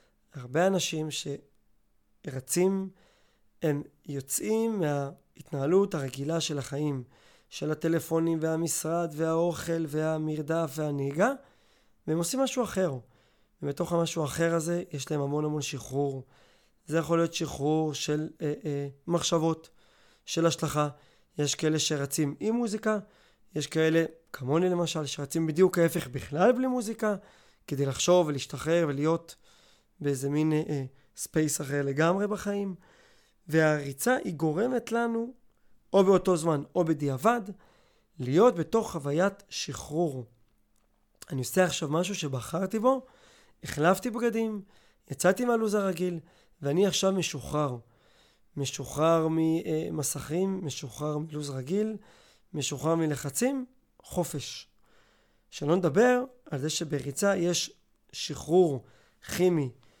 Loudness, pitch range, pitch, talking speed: -29 LUFS, 145-185 Hz, 160 Hz, 105 wpm